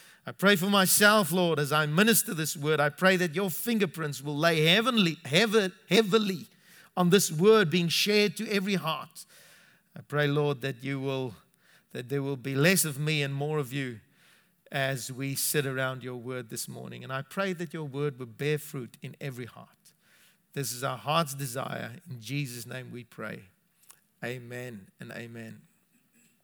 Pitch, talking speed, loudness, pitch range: 150 Hz, 175 wpm, -27 LUFS, 135-185 Hz